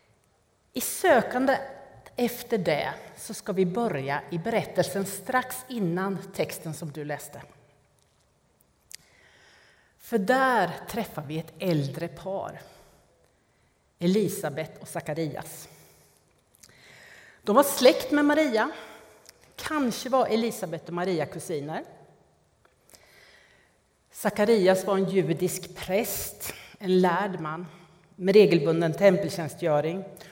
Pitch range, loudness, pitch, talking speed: 170-220 Hz, -26 LUFS, 190 Hz, 95 wpm